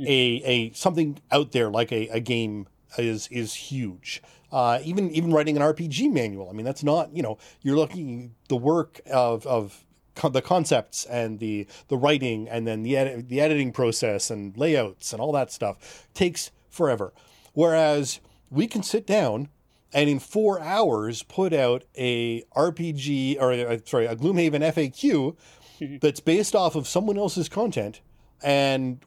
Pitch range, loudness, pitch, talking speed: 120-160 Hz, -25 LUFS, 140 Hz, 165 wpm